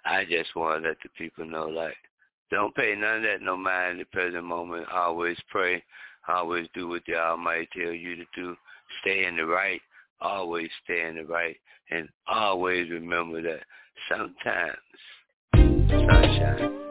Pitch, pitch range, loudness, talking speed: 85 Hz, 85-90 Hz, -27 LUFS, 165 wpm